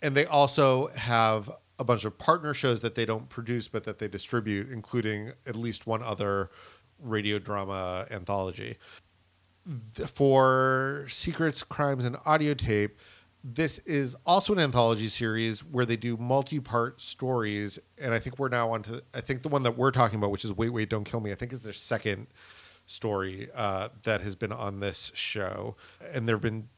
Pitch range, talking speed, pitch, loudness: 105-130 Hz, 185 wpm, 115 Hz, -28 LUFS